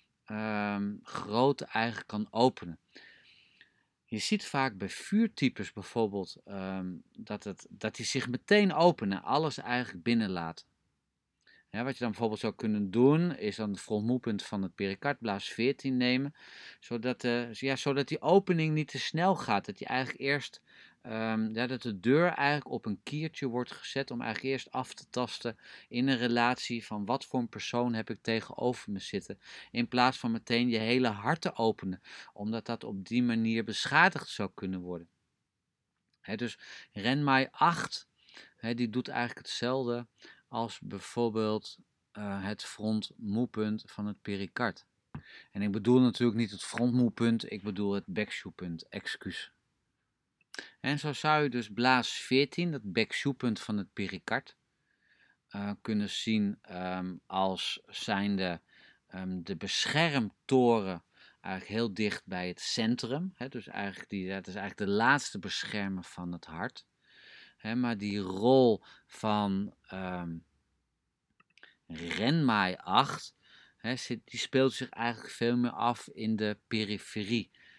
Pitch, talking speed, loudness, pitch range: 115 Hz, 145 wpm, -32 LUFS, 100-130 Hz